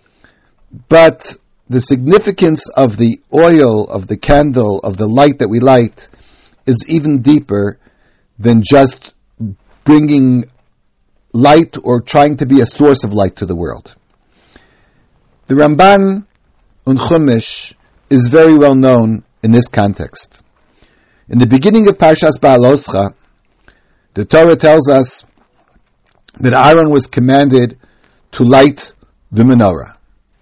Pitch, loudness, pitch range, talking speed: 130 Hz, -9 LUFS, 110-150 Hz, 120 wpm